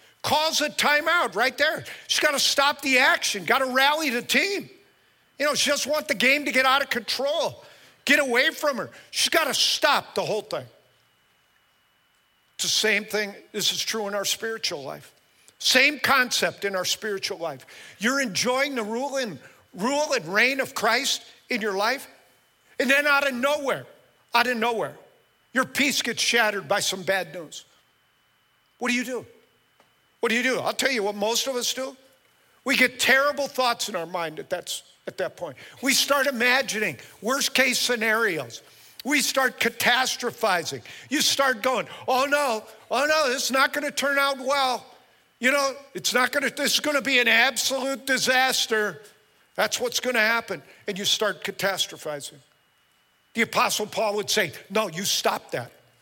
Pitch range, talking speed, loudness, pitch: 215-275 Hz, 180 wpm, -23 LUFS, 250 Hz